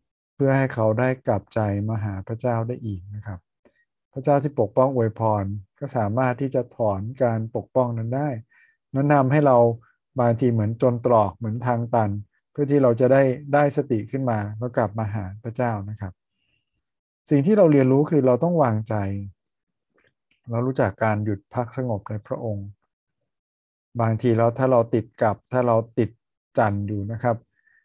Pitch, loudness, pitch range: 120 Hz, -22 LUFS, 110-130 Hz